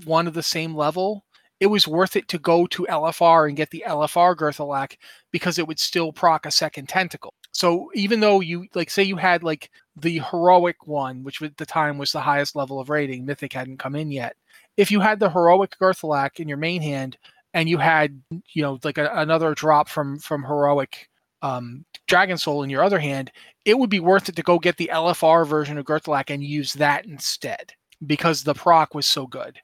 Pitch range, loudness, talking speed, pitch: 145-175 Hz, -21 LUFS, 215 wpm, 160 Hz